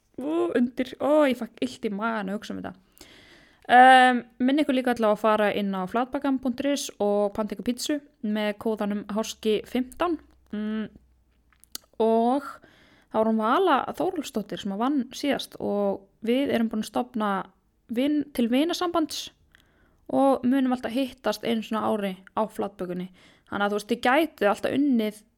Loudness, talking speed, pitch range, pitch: -25 LUFS, 165 wpm, 210-270 Hz, 235 Hz